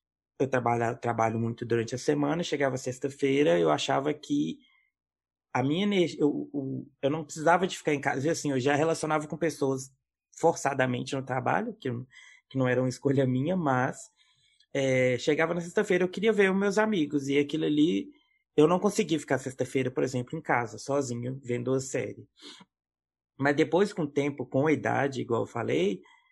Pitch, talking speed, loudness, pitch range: 140 Hz, 180 wpm, -28 LUFS, 130-165 Hz